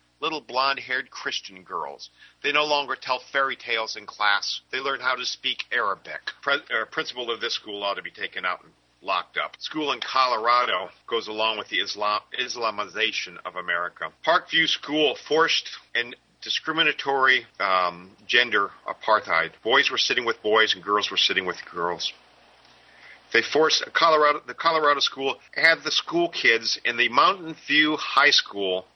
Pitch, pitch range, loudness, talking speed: 125 Hz, 105-150 Hz, -23 LUFS, 160 wpm